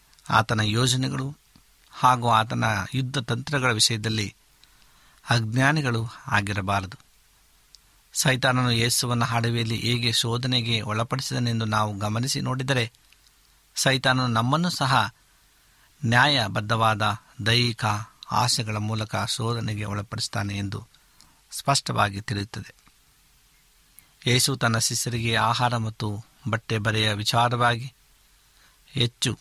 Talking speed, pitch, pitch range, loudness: 80 wpm, 115 Hz, 110-125 Hz, -24 LUFS